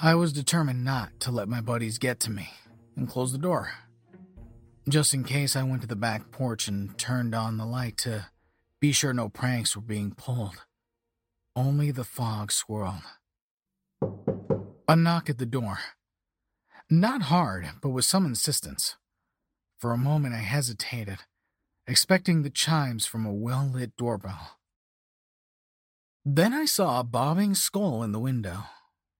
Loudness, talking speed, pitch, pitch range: -27 LUFS, 150 wpm, 120 Hz, 110-145 Hz